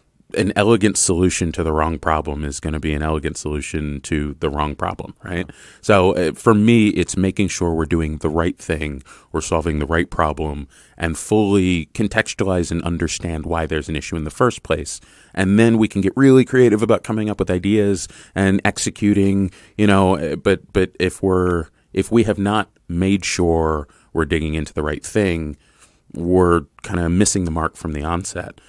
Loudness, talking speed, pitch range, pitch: -19 LUFS, 185 wpm, 80-100 Hz, 85 Hz